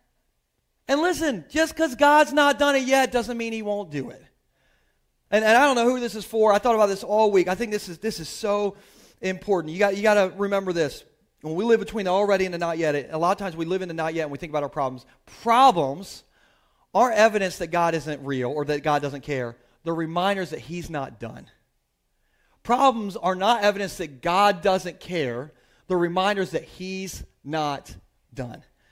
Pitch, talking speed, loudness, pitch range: 190 Hz, 215 wpm, -23 LUFS, 160-215 Hz